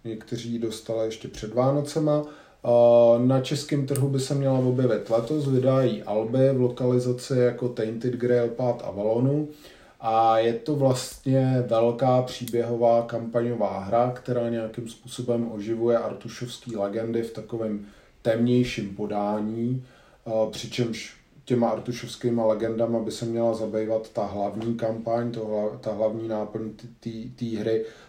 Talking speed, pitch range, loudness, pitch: 125 wpm, 110-125 Hz, -25 LUFS, 115 Hz